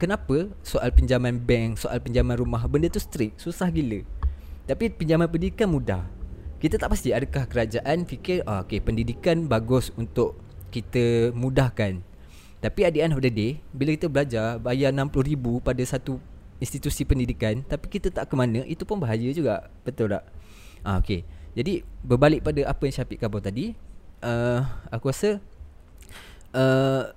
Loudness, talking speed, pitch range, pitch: -25 LUFS, 150 wpm, 105-140 Hz, 125 Hz